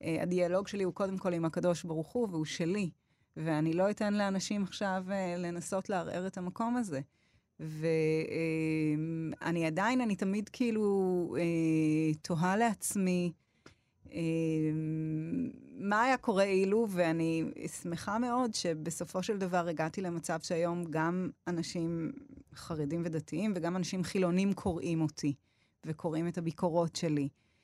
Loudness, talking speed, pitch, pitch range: -33 LUFS, 130 wpm, 175 Hz, 160-195 Hz